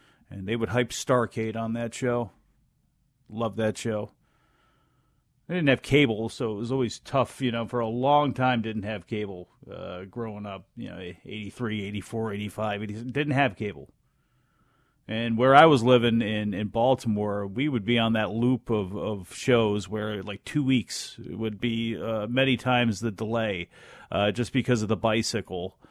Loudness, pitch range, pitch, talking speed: -26 LUFS, 105-125 Hz, 115 Hz, 170 wpm